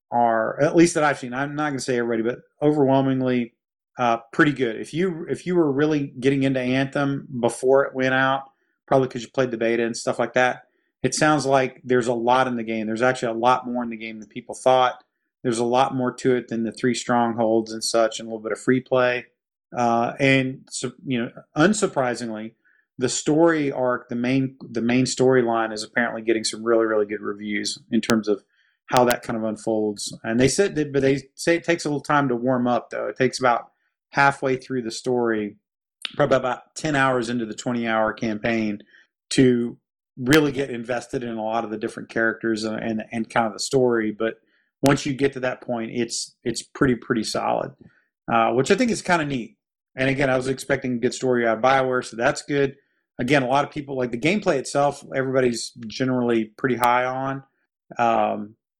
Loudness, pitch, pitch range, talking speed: -22 LUFS, 125 Hz, 115-135 Hz, 210 wpm